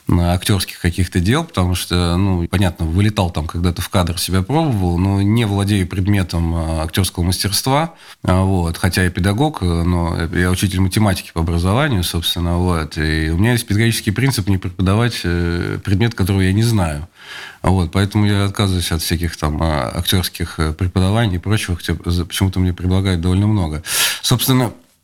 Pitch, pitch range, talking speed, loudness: 95 Hz, 85-100 Hz, 155 wpm, -17 LUFS